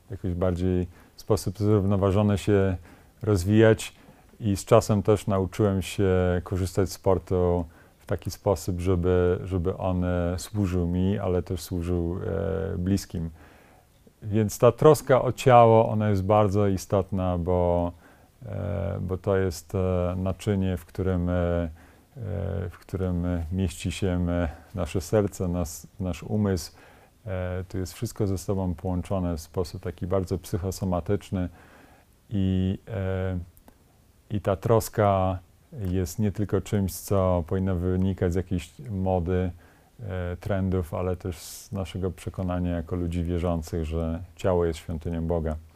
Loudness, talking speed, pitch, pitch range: -26 LUFS, 125 wpm, 95 Hz, 90-100 Hz